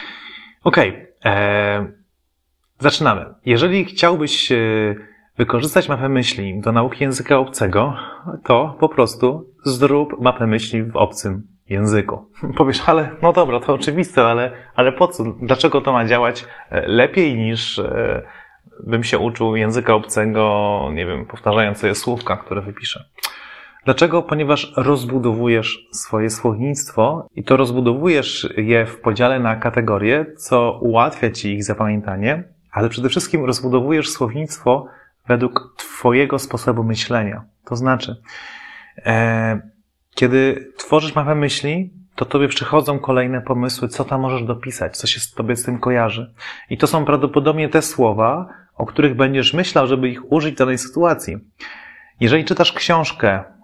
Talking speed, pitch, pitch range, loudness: 135 wpm, 125 Hz, 115-145 Hz, -17 LUFS